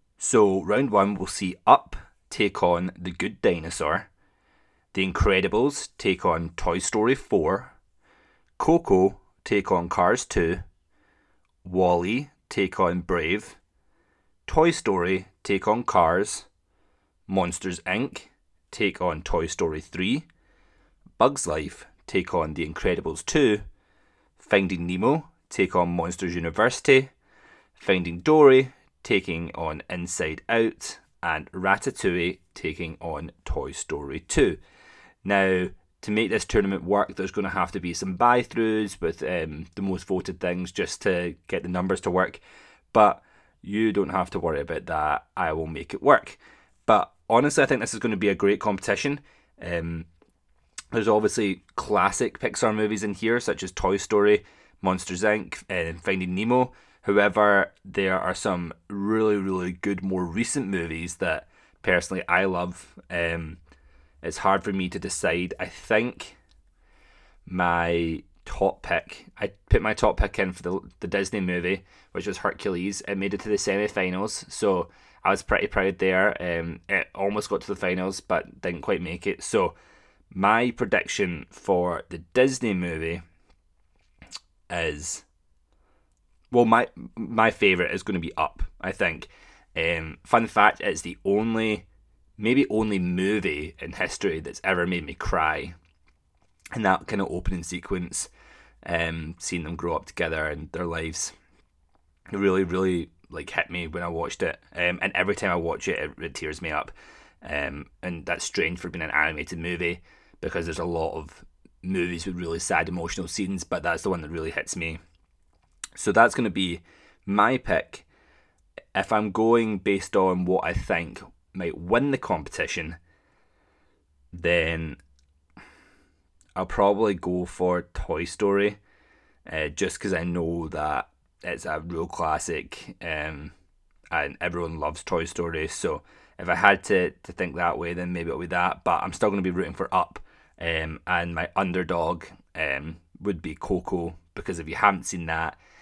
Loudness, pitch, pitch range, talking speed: -25 LUFS, 90 Hz, 85-100 Hz, 155 wpm